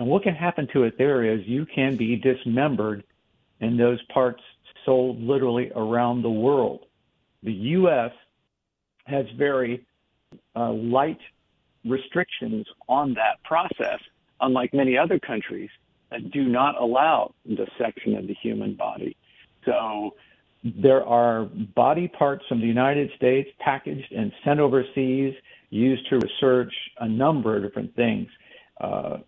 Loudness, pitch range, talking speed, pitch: -24 LUFS, 120-140 Hz, 135 wpm, 130 Hz